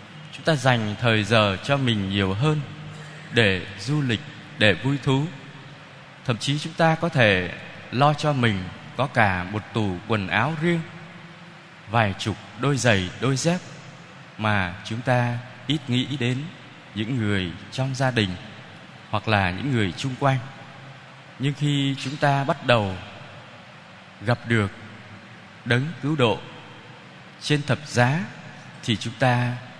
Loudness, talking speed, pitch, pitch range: -23 LUFS, 145 wpm, 125 Hz, 110-145 Hz